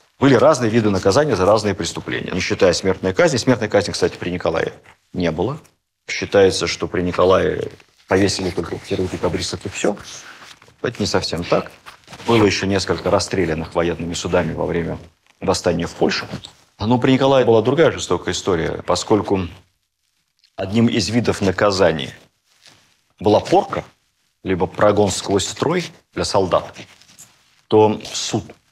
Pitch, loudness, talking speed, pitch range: 100 Hz, -18 LUFS, 135 wpm, 90-110 Hz